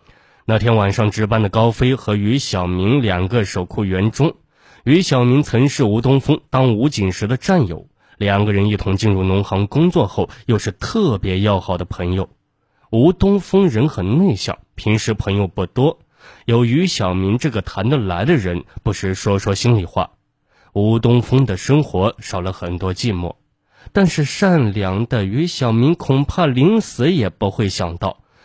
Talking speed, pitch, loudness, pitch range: 245 characters per minute, 110 Hz, -17 LUFS, 95-135 Hz